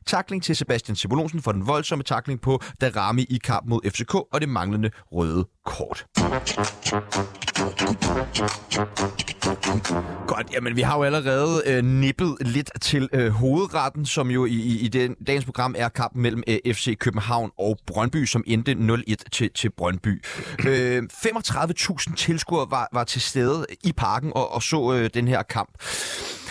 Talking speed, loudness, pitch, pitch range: 155 wpm, -24 LUFS, 125 Hz, 105-140 Hz